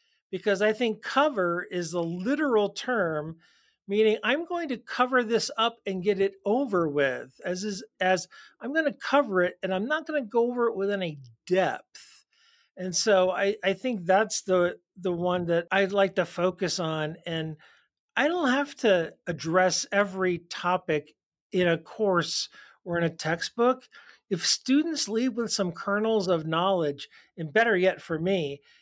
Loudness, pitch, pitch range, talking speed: -27 LUFS, 195 Hz, 175-235 Hz, 170 wpm